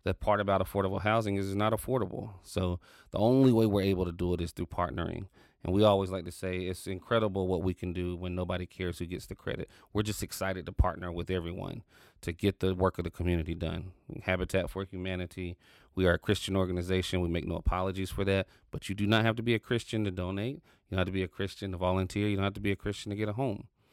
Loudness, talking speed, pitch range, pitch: -32 LUFS, 250 wpm, 90-105 Hz, 95 Hz